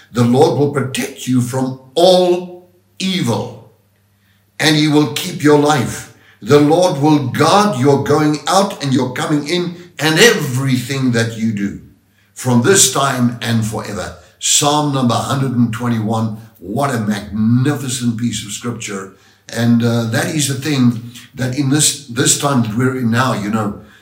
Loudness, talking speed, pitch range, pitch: -15 LUFS, 150 wpm, 115-150 Hz, 130 Hz